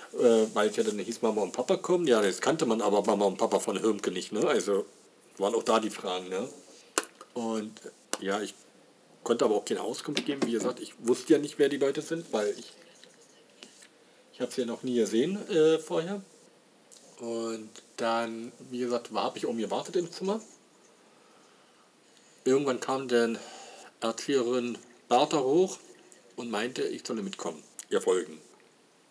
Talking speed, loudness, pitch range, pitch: 170 wpm, -29 LUFS, 115-155 Hz, 125 Hz